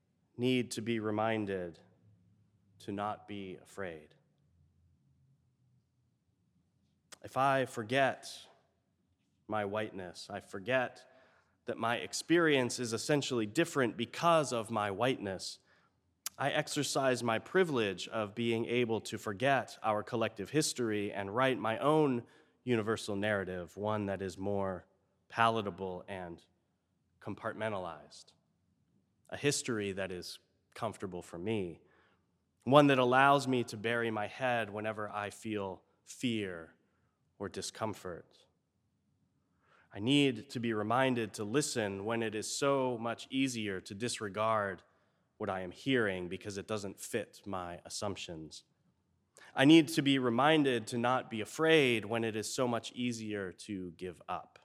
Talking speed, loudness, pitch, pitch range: 125 wpm, -33 LUFS, 110 Hz, 100-125 Hz